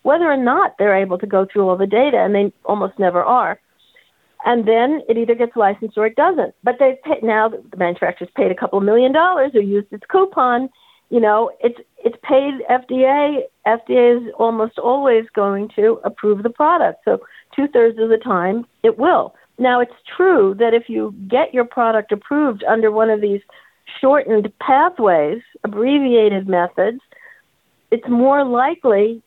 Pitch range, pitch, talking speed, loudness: 210-265 Hz, 230 Hz, 170 wpm, -16 LUFS